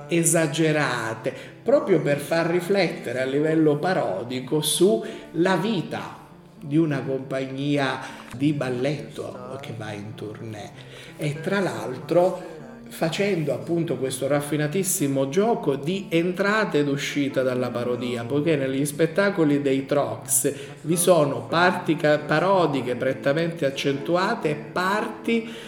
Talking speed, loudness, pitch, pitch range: 110 wpm, -23 LUFS, 150 Hz, 135-175 Hz